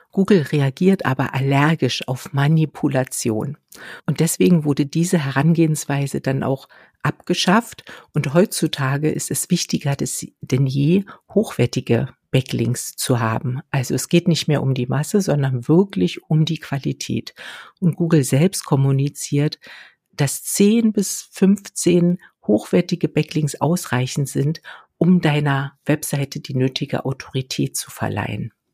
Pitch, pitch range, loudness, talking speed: 145 Hz, 135-170 Hz, -20 LUFS, 120 wpm